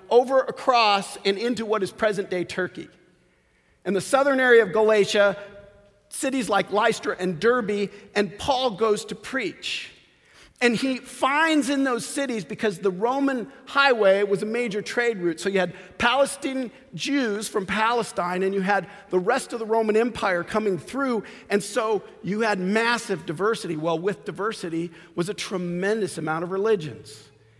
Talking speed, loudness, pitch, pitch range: 155 wpm, -24 LUFS, 210 Hz, 190-240 Hz